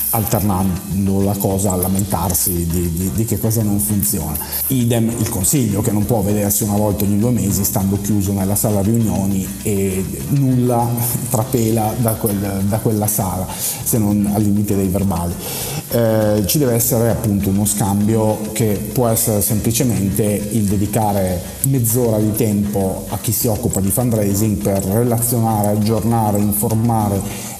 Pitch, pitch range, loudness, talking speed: 105 Hz, 100-115 Hz, -17 LUFS, 150 wpm